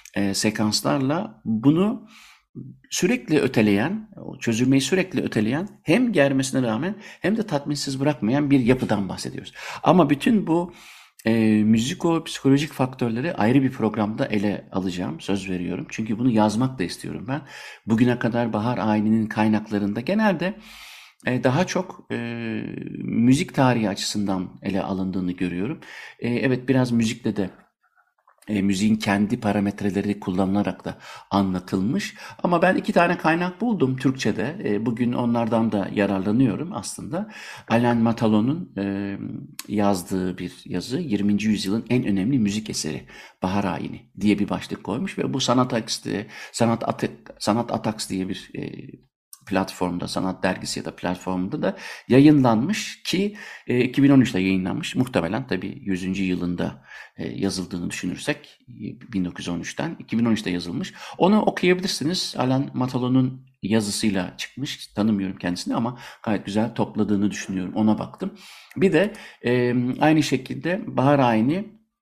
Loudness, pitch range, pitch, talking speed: -23 LUFS, 100-135 Hz, 110 Hz, 125 wpm